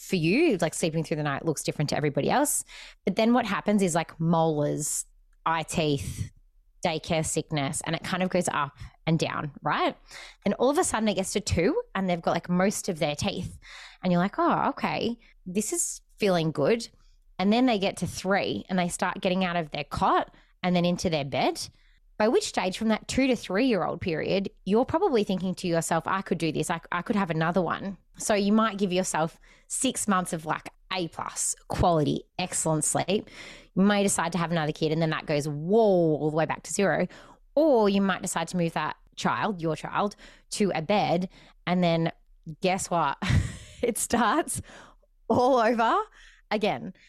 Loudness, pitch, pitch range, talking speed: -27 LUFS, 180 Hz, 160-210 Hz, 200 wpm